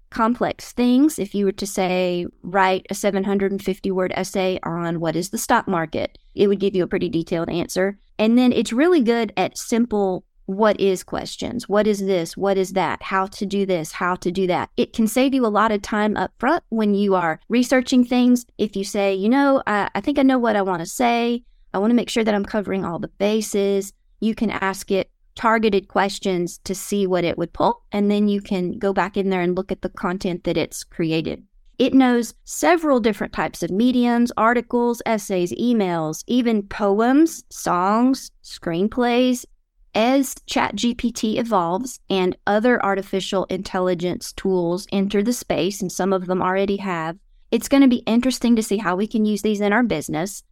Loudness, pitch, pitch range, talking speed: -21 LUFS, 200 Hz, 185-230 Hz, 195 wpm